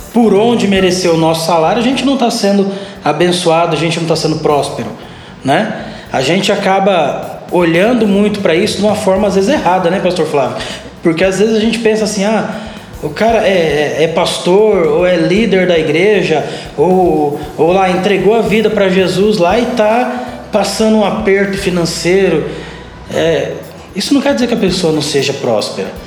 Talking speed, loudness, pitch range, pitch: 185 wpm, -12 LUFS, 170-210 Hz, 195 Hz